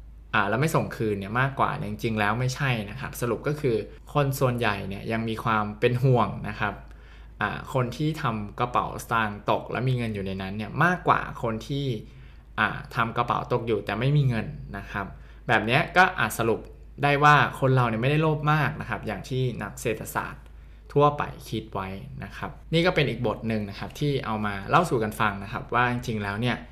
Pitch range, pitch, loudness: 105-135 Hz, 115 Hz, -26 LUFS